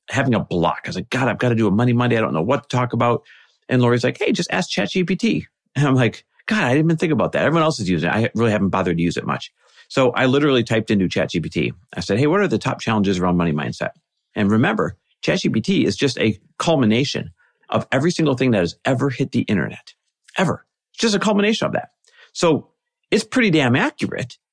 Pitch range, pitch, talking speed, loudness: 105-150 Hz, 125 Hz, 240 wpm, -19 LUFS